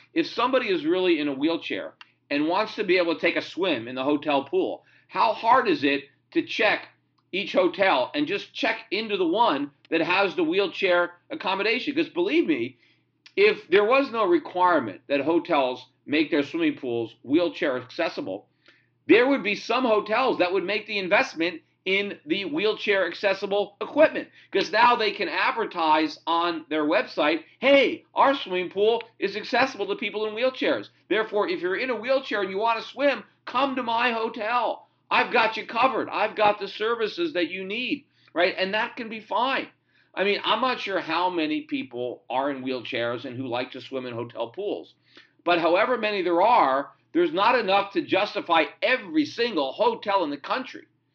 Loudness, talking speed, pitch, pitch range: -24 LUFS, 180 wpm, 215 Hz, 175-290 Hz